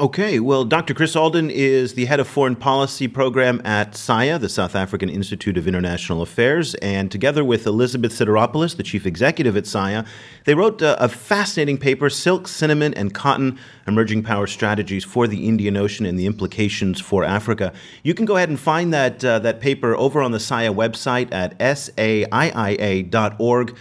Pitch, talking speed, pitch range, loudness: 120 Hz, 175 wpm, 100-140 Hz, -19 LUFS